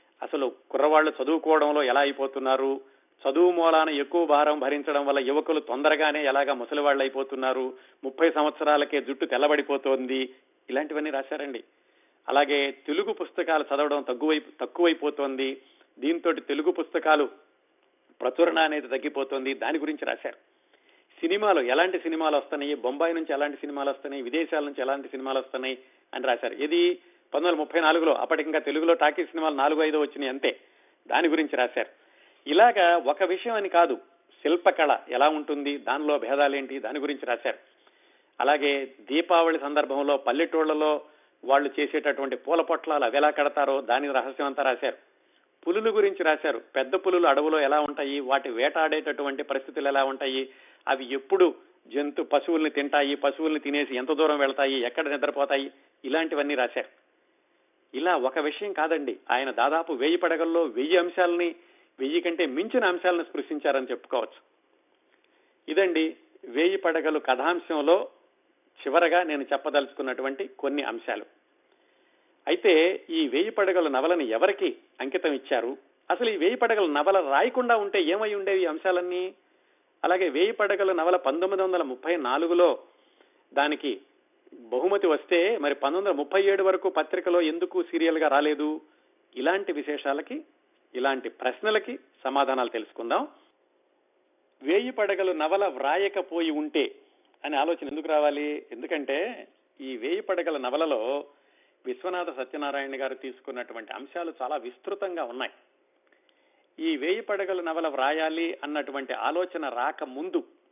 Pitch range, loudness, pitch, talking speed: 140-180 Hz, -26 LUFS, 155 Hz, 120 wpm